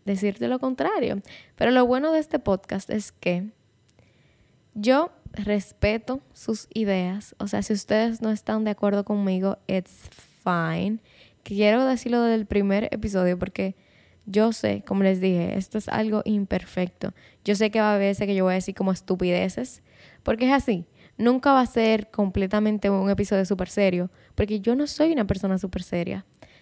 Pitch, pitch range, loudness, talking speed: 205 Hz, 190-220 Hz, -24 LUFS, 170 wpm